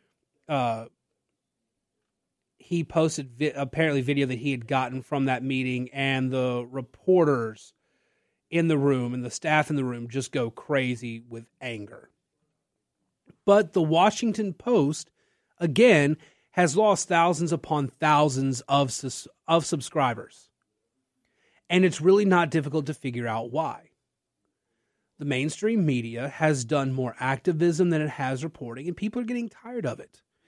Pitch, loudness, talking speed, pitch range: 145 Hz, -25 LUFS, 140 wpm, 130-170 Hz